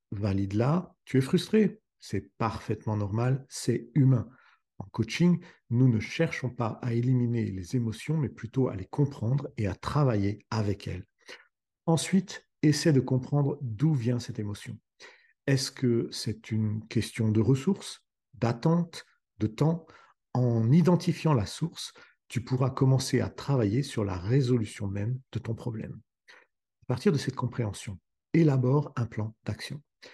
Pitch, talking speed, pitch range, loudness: 125 Hz, 145 wpm, 110-145 Hz, -29 LUFS